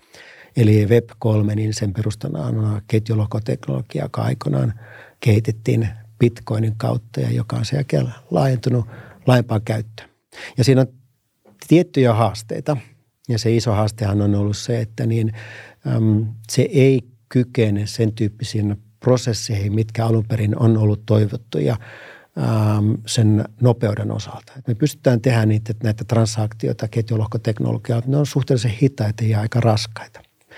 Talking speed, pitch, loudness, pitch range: 130 wpm, 115 Hz, -20 LUFS, 110-125 Hz